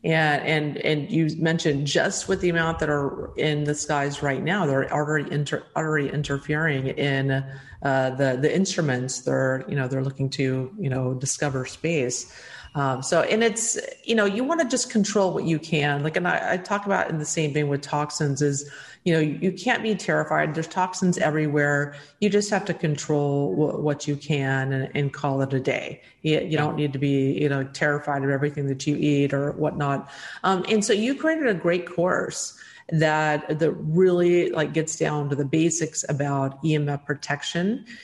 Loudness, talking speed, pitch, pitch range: -24 LUFS, 200 wpm, 150 Hz, 140-170 Hz